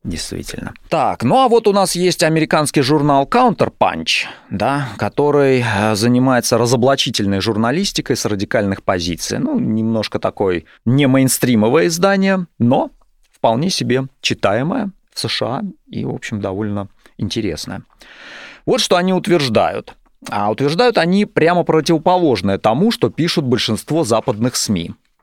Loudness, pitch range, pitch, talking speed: -16 LUFS, 110-170 Hz, 135 Hz, 120 wpm